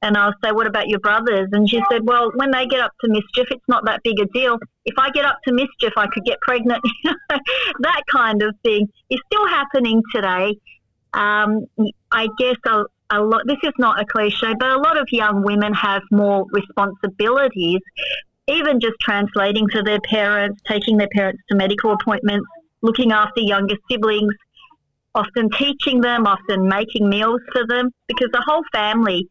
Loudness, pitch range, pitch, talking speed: -18 LUFS, 205-250 Hz, 225 Hz, 180 wpm